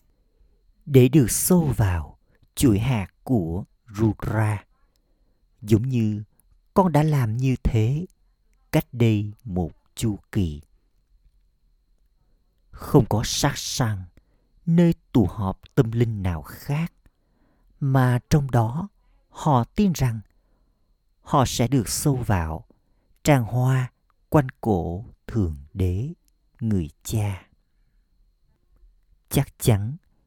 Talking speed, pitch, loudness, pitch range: 105 wpm, 110 Hz, -23 LUFS, 90-130 Hz